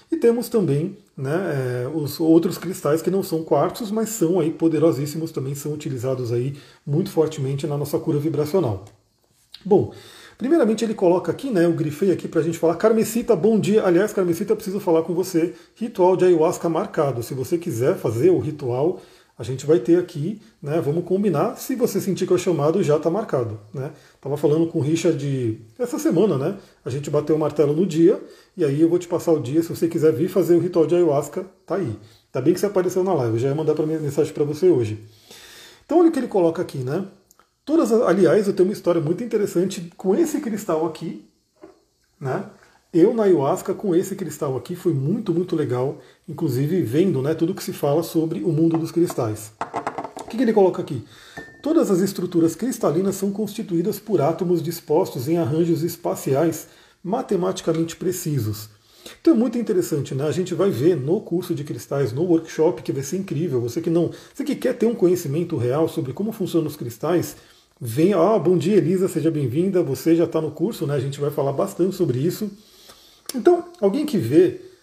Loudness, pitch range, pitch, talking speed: -21 LUFS, 155-190 Hz, 170 Hz, 200 wpm